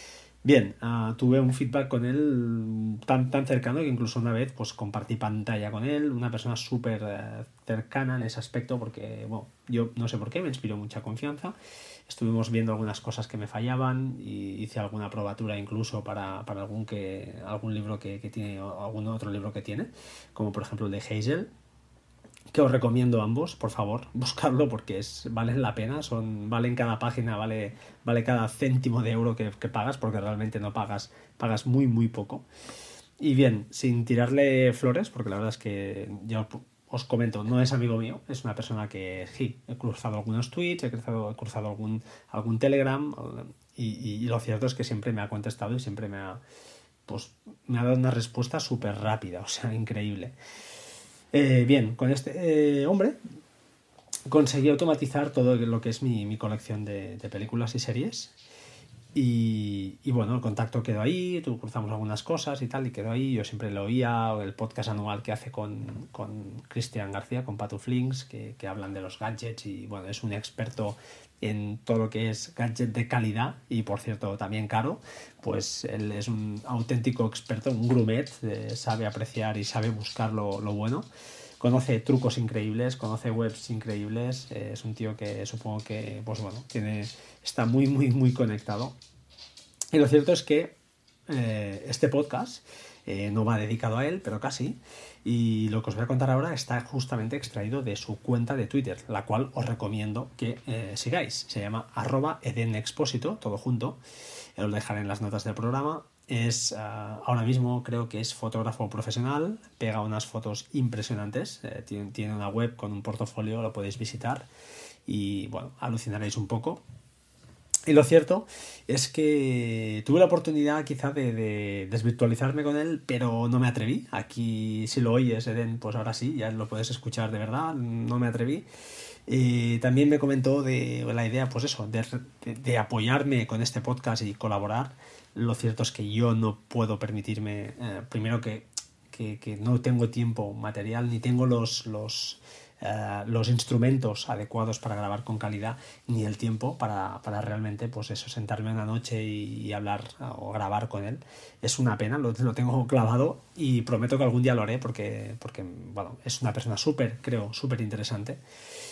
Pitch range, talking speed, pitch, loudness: 110-125 Hz, 180 wpm, 115 Hz, -29 LUFS